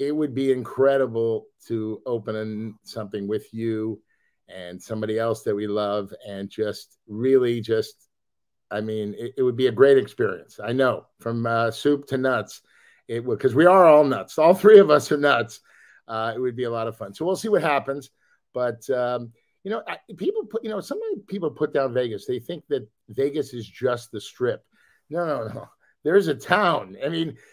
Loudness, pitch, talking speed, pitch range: -23 LUFS, 125 Hz, 200 wpm, 110-140 Hz